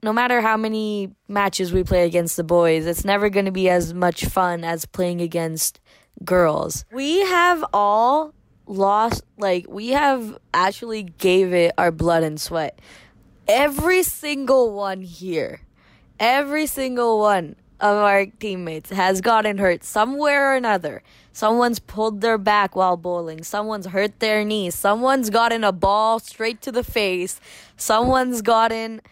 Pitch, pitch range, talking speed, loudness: 205 Hz, 185-230 Hz, 150 wpm, -20 LUFS